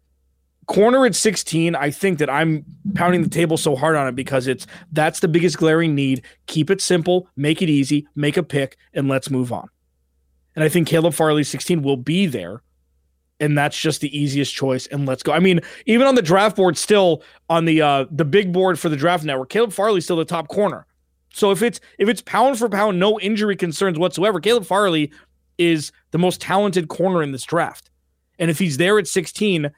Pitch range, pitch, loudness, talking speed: 140-190 Hz, 165 Hz, -19 LUFS, 210 wpm